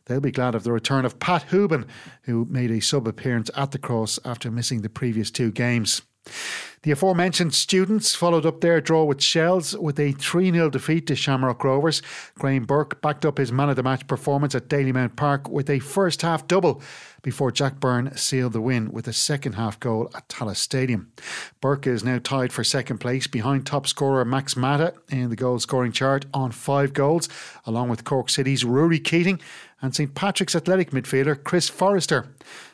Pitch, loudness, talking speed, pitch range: 135 Hz, -23 LUFS, 185 wpm, 125-155 Hz